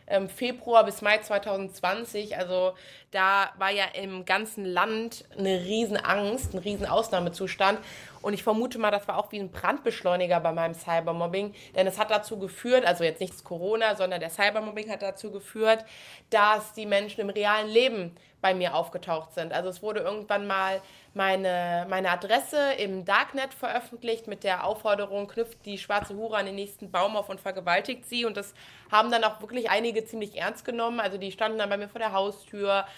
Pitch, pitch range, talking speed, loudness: 200 Hz, 190-215 Hz, 180 wpm, -28 LUFS